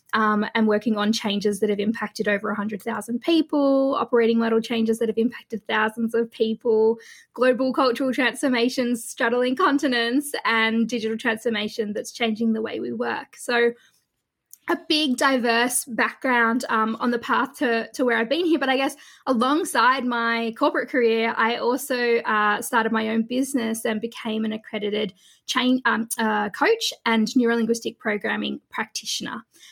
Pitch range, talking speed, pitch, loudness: 225-255 Hz, 150 wpm, 230 Hz, -22 LUFS